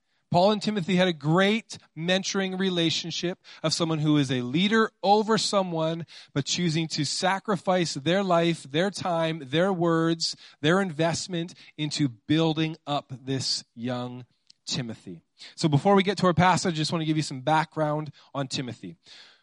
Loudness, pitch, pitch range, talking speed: -26 LUFS, 165 Hz, 145-185 Hz, 160 wpm